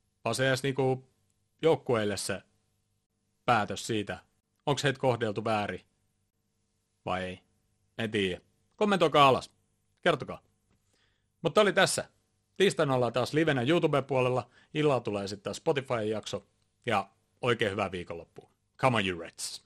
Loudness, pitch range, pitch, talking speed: -29 LUFS, 105-130 Hz, 110 Hz, 115 wpm